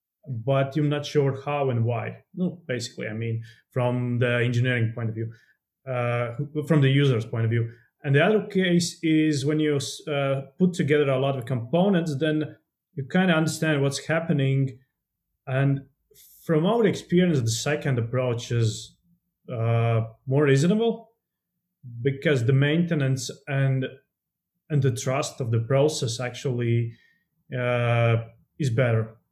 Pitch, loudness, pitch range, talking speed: 135 Hz, -24 LUFS, 120-155 Hz, 145 wpm